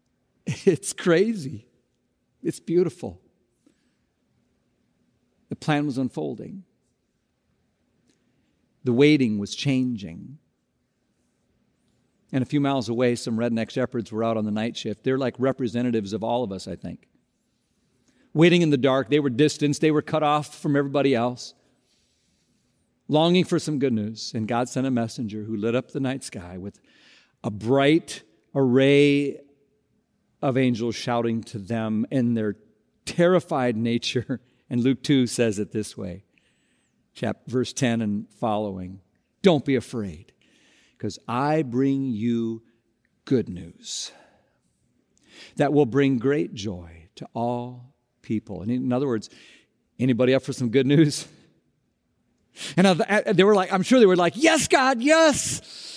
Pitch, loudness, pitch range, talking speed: 125 Hz, -23 LUFS, 115-145 Hz, 140 wpm